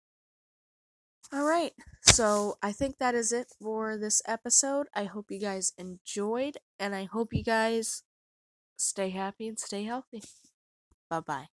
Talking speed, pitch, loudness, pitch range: 145 wpm, 220 Hz, -29 LUFS, 200-245 Hz